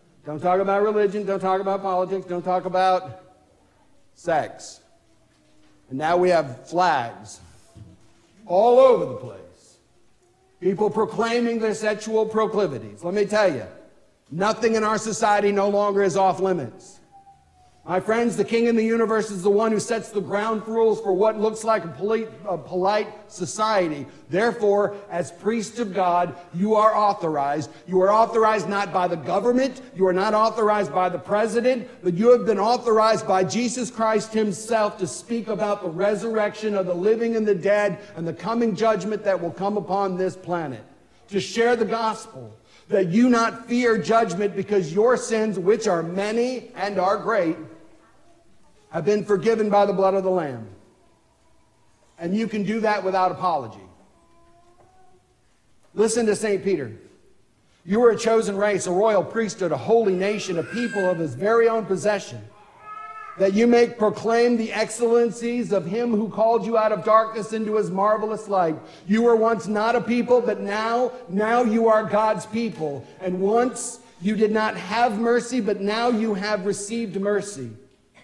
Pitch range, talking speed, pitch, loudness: 190-225 Hz, 165 wpm, 210 Hz, -22 LUFS